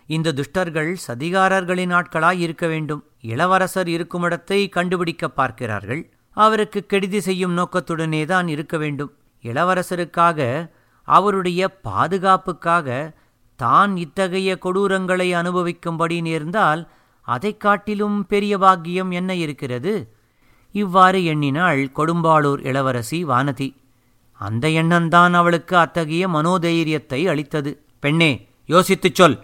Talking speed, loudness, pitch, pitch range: 95 wpm, -19 LUFS, 170 Hz, 145-185 Hz